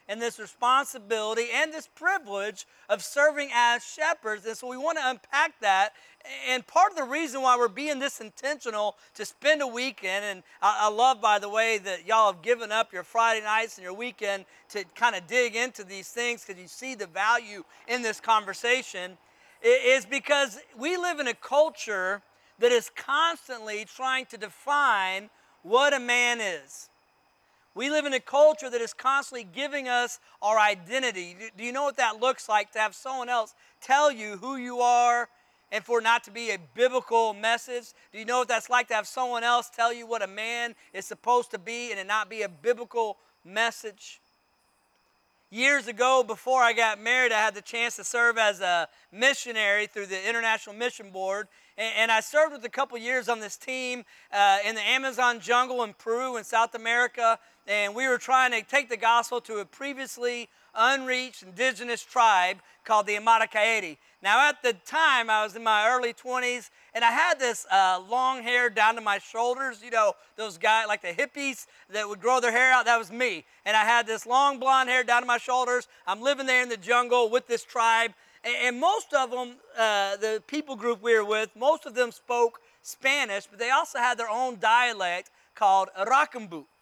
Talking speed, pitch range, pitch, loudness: 195 wpm, 215-255 Hz, 235 Hz, -26 LUFS